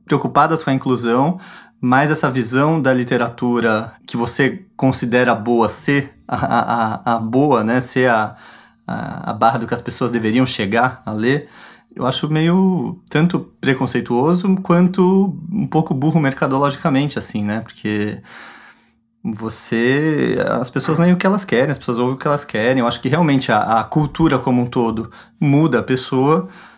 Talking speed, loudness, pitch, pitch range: 165 wpm, -17 LUFS, 130 Hz, 120-155 Hz